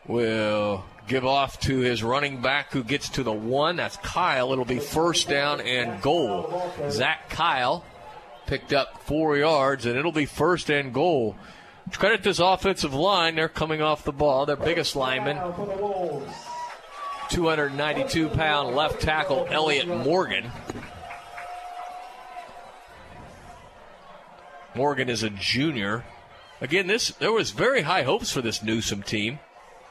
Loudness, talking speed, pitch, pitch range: -24 LUFS, 130 wpm, 145 Hz, 125-170 Hz